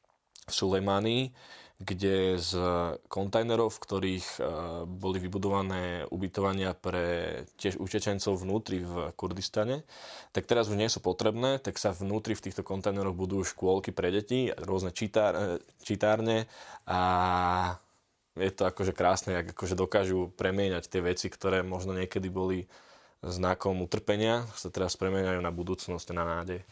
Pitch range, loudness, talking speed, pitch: 90-105 Hz, -31 LUFS, 130 wpm, 95 Hz